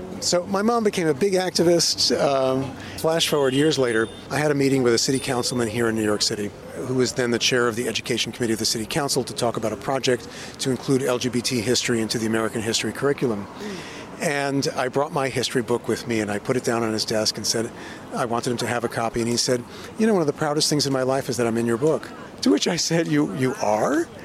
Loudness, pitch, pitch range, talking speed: -22 LUFS, 125 Hz, 115-140 Hz, 255 wpm